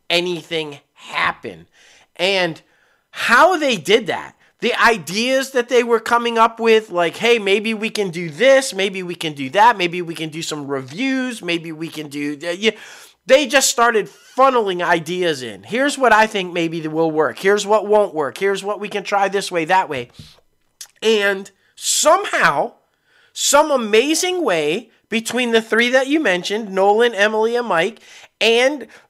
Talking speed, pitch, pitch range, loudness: 165 wpm, 210 Hz, 175-240 Hz, -17 LUFS